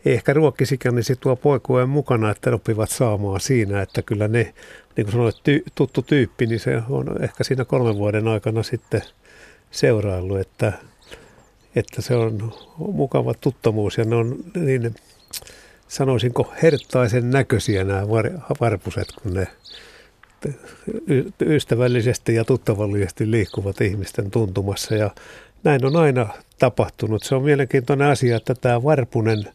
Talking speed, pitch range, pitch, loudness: 135 wpm, 110-130 Hz, 120 Hz, -21 LUFS